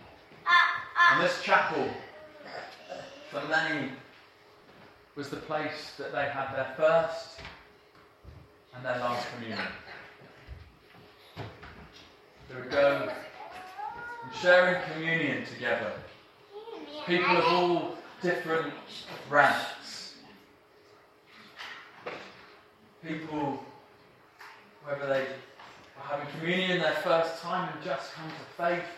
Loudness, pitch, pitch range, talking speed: -29 LUFS, 160 Hz, 140-180 Hz, 90 wpm